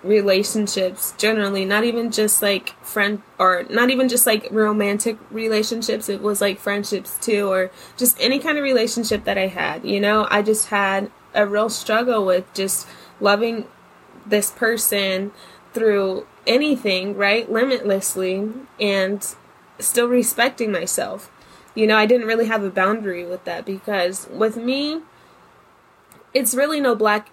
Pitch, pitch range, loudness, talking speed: 210 Hz, 200-230 Hz, -20 LUFS, 145 wpm